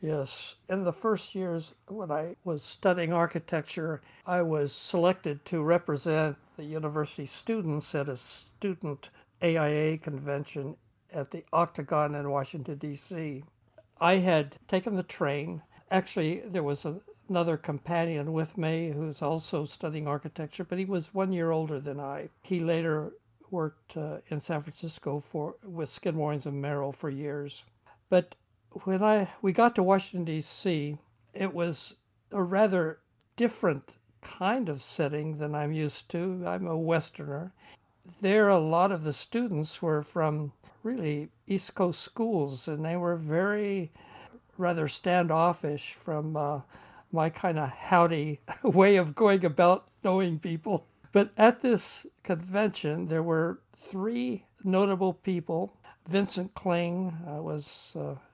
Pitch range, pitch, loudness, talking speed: 150-185 Hz, 165 Hz, -30 LUFS, 135 wpm